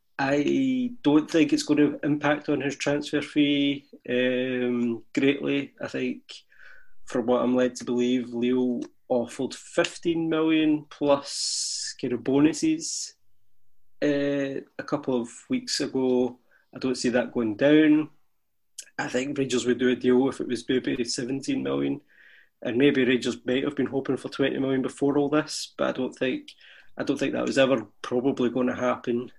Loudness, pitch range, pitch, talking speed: -26 LUFS, 125-150 Hz, 135 Hz, 165 wpm